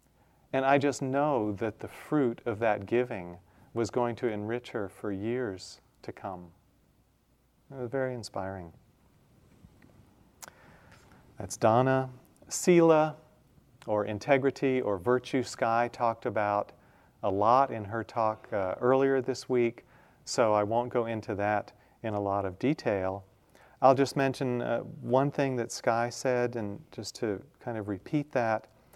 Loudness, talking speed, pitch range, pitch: -29 LUFS, 145 wpm, 105-130 Hz, 115 Hz